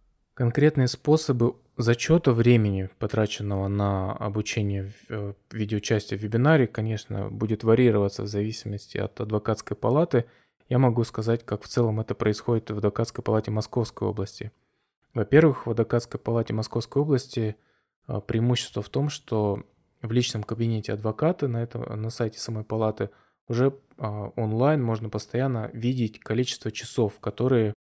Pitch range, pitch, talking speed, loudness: 105-125 Hz, 115 Hz, 125 wpm, -26 LUFS